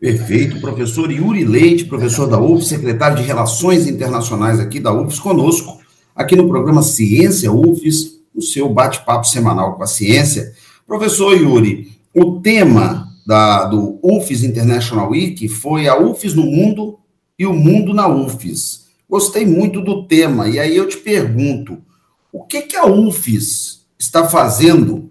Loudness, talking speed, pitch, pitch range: -13 LUFS, 150 wpm, 150 Hz, 115-175 Hz